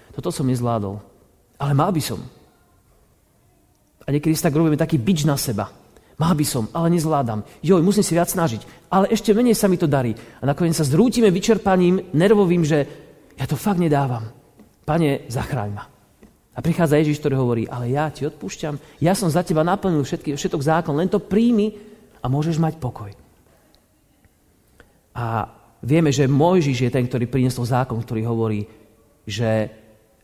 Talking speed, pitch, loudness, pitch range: 165 wpm, 145 Hz, -20 LUFS, 120-170 Hz